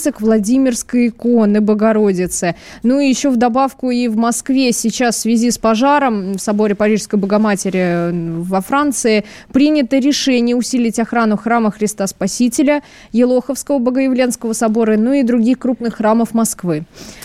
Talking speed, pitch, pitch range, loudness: 135 wpm, 230 Hz, 210-255 Hz, -15 LUFS